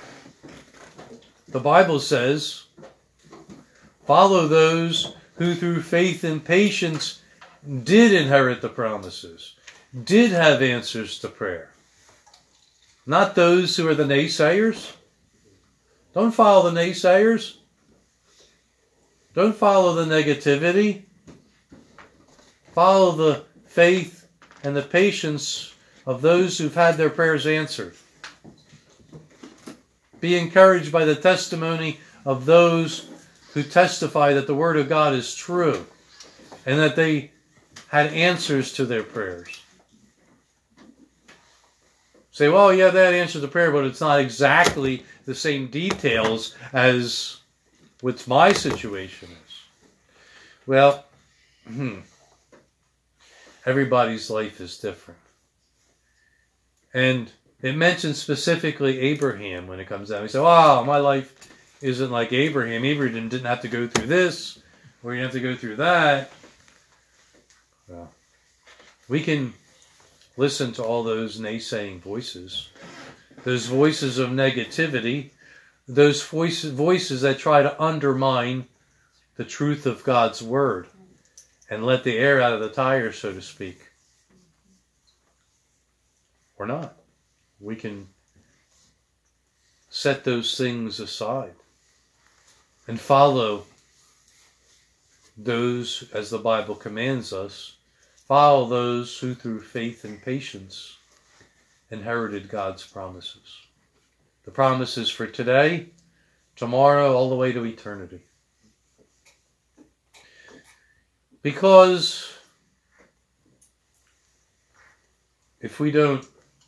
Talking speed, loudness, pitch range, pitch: 105 wpm, -20 LUFS, 120-165 Hz, 140 Hz